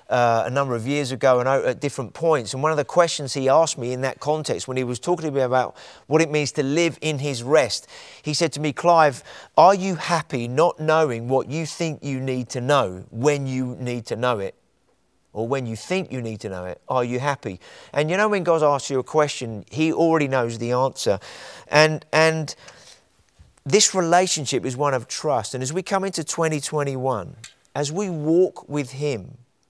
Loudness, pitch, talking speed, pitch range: -22 LUFS, 145 Hz, 210 wpm, 125-160 Hz